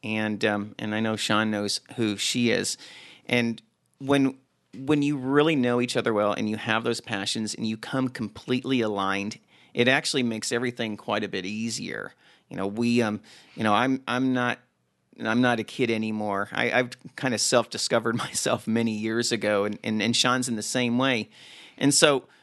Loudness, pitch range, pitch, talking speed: -25 LUFS, 105-125 Hz, 115 Hz, 185 wpm